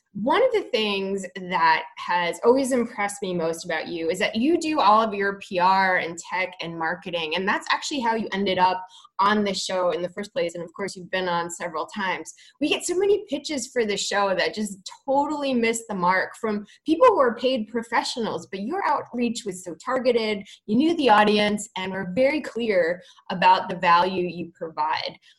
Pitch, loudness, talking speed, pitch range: 205 Hz, -23 LUFS, 200 wpm, 180-250 Hz